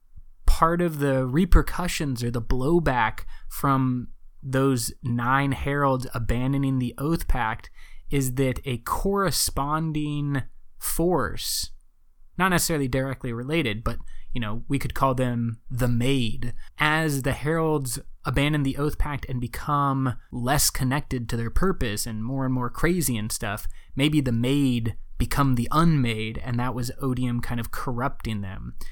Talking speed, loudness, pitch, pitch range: 140 wpm, -25 LUFS, 130 Hz, 120-145 Hz